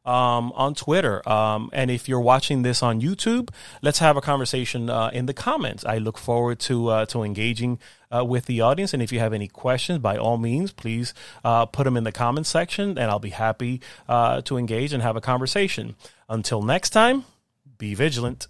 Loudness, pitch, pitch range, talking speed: -23 LUFS, 125 Hz, 115-135 Hz, 205 wpm